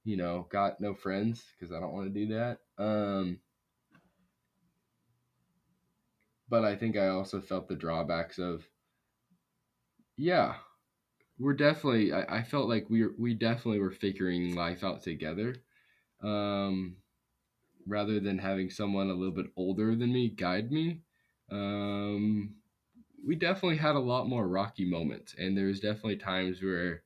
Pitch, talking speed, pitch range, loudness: 100 Hz, 145 wpm, 95-115 Hz, -32 LUFS